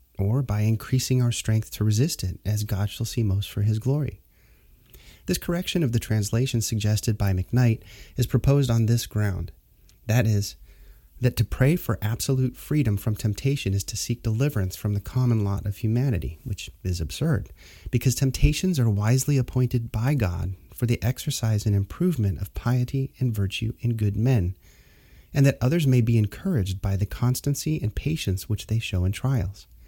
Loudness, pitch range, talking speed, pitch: -25 LUFS, 100-130 Hz, 175 wpm, 110 Hz